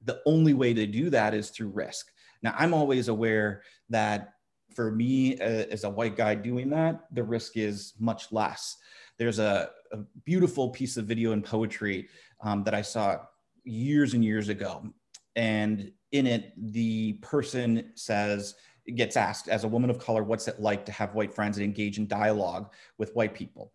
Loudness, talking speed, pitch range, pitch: -29 LUFS, 180 wpm, 105-120 Hz, 110 Hz